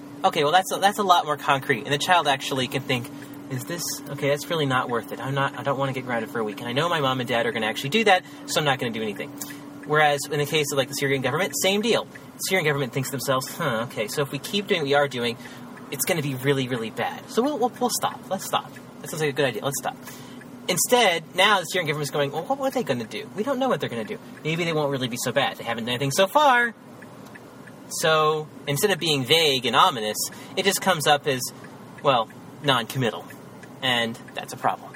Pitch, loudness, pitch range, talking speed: 145 Hz, -23 LUFS, 135-185 Hz, 270 wpm